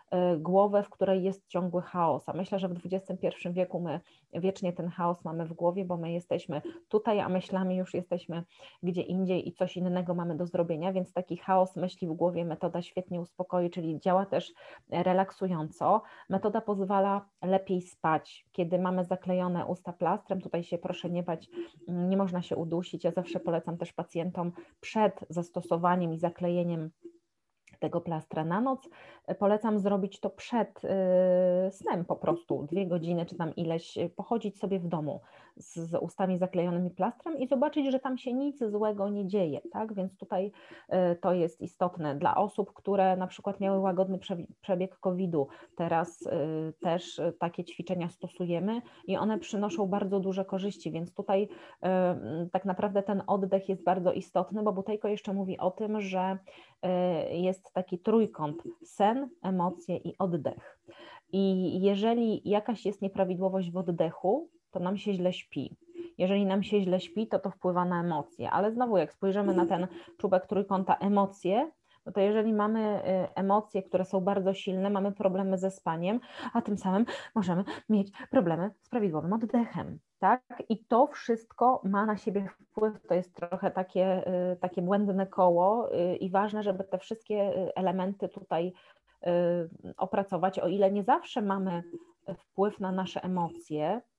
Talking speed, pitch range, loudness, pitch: 155 wpm, 175-200 Hz, -31 LUFS, 185 Hz